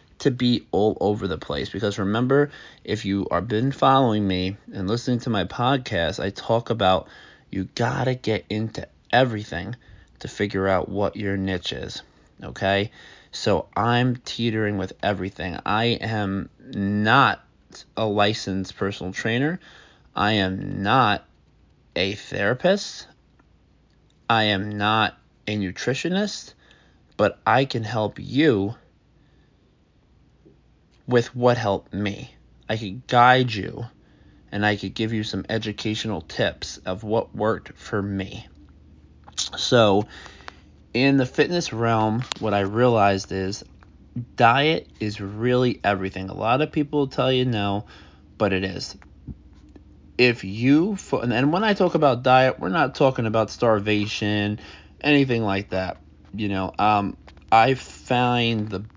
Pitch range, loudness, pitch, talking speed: 95-125 Hz, -23 LUFS, 105 Hz, 130 wpm